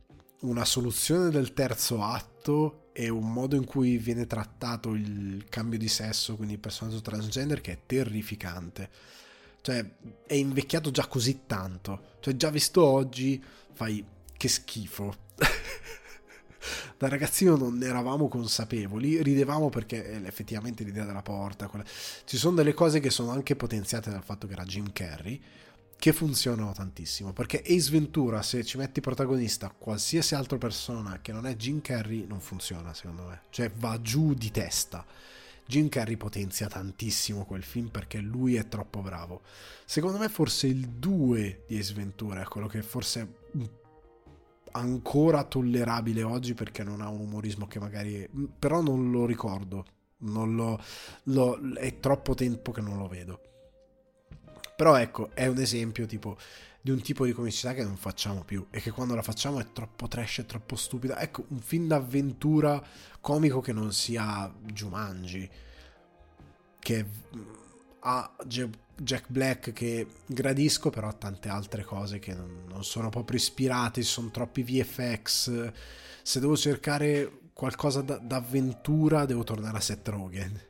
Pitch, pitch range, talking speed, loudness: 115 Hz, 105-135 Hz, 150 wpm, -30 LUFS